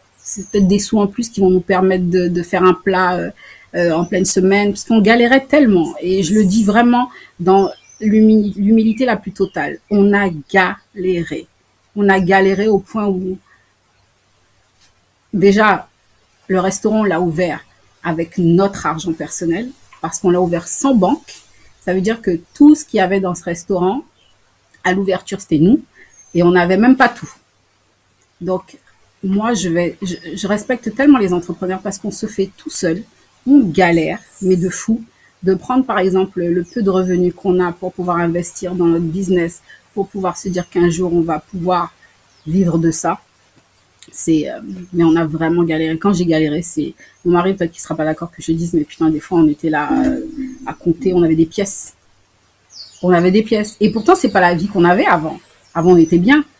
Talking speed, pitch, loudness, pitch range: 195 wpm, 185 Hz, -15 LUFS, 165-200 Hz